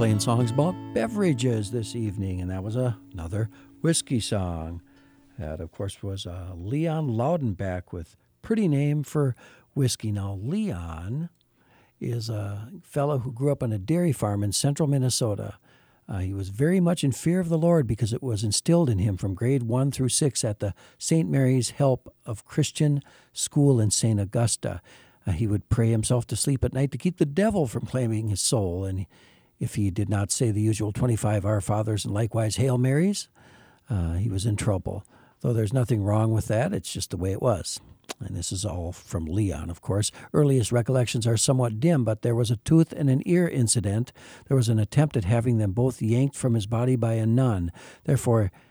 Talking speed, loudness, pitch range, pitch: 195 wpm, -25 LUFS, 105-135 Hz, 120 Hz